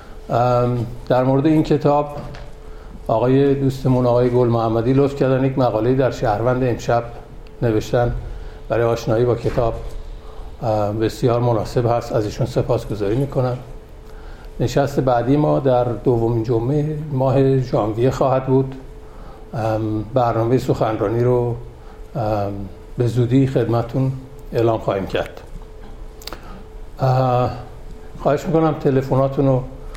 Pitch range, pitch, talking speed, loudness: 115-135 Hz, 125 Hz, 105 wpm, -19 LUFS